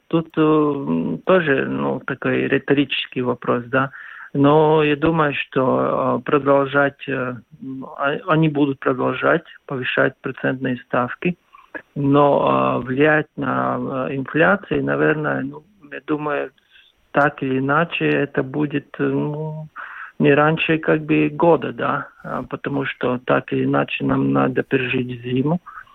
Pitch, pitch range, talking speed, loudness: 140 Hz, 130-155 Hz, 110 wpm, -19 LUFS